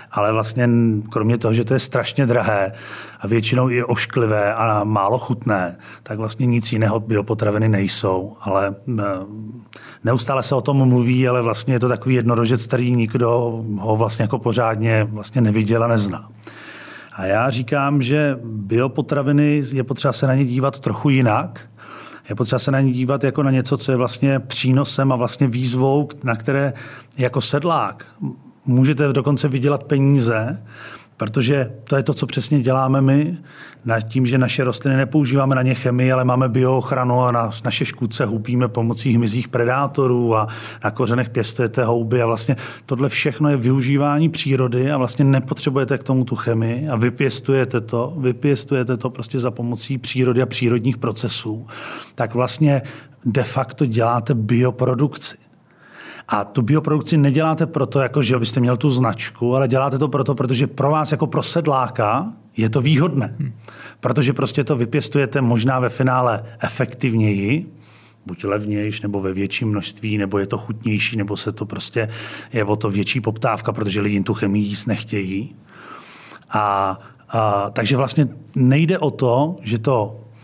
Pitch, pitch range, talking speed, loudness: 125 Hz, 115-135 Hz, 160 wpm, -19 LUFS